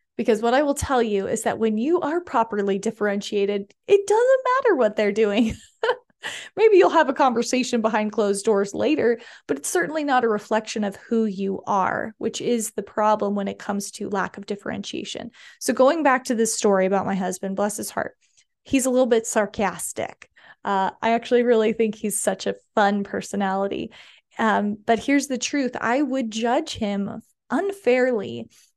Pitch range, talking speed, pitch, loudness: 205-255 Hz, 180 wpm, 225 Hz, -22 LUFS